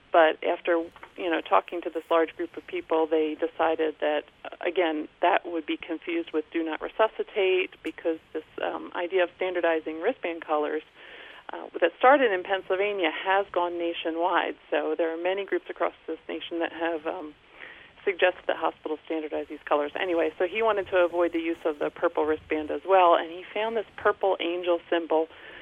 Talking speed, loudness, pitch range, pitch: 180 wpm, -27 LUFS, 160-185 Hz, 170 Hz